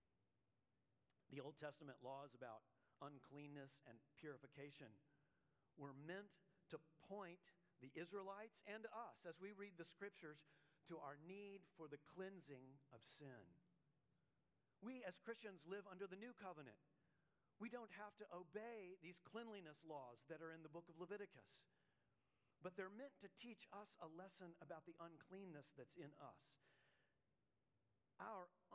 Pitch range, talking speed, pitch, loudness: 140-195 Hz, 140 wpm, 165 Hz, -59 LUFS